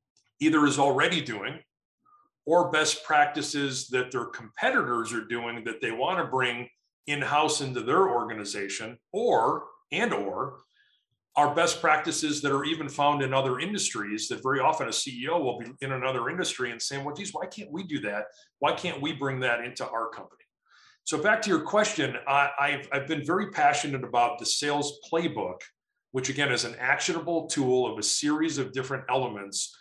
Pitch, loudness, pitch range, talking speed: 140 Hz, -27 LUFS, 125-155 Hz, 175 wpm